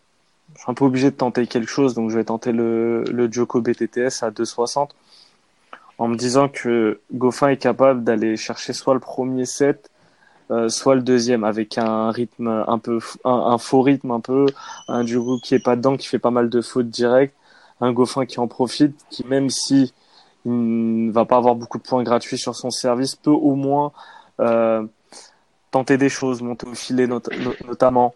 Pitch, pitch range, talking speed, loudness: 125 Hz, 115-130 Hz, 200 wpm, -20 LUFS